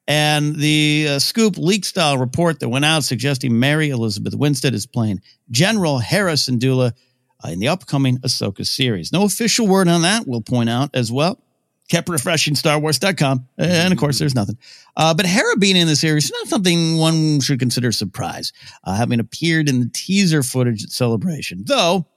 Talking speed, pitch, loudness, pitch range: 185 wpm, 150 Hz, -17 LUFS, 125-170 Hz